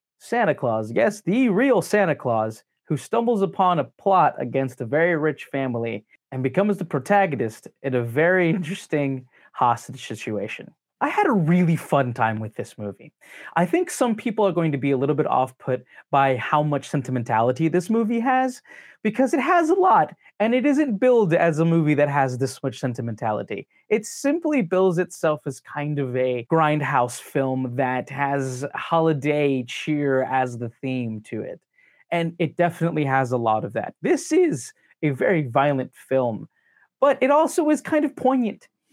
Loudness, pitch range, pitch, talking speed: -22 LUFS, 130-205 Hz, 150 Hz, 175 wpm